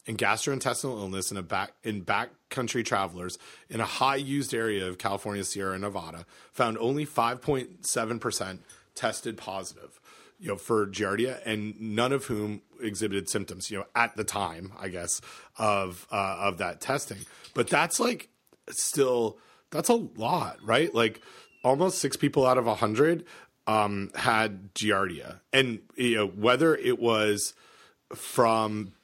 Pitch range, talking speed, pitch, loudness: 100-130 Hz, 155 wpm, 110 Hz, -28 LUFS